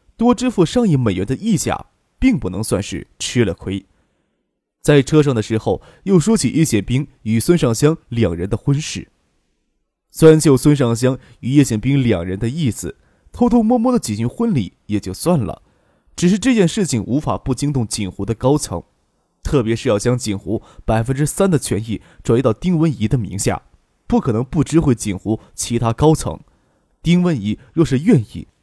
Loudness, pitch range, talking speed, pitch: -17 LUFS, 105-160 Hz, 260 characters per minute, 125 Hz